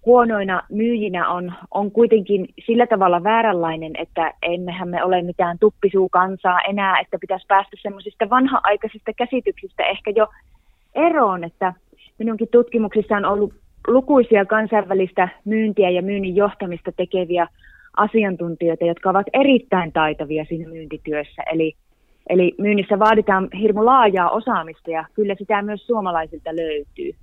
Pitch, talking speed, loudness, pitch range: 195 Hz, 125 wpm, -19 LUFS, 175-220 Hz